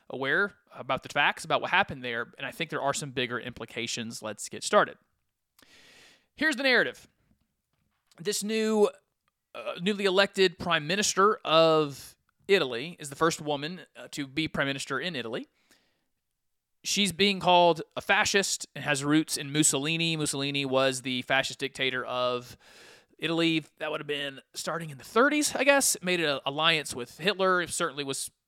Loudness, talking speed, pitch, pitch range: -27 LUFS, 160 wpm, 155 Hz, 135-185 Hz